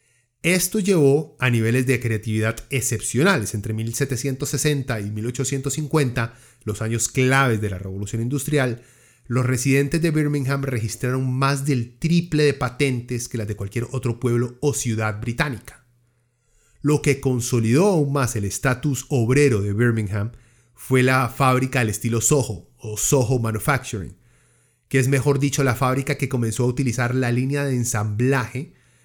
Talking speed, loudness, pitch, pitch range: 145 wpm, -21 LUFS, 125 Hz, 115-140 Hz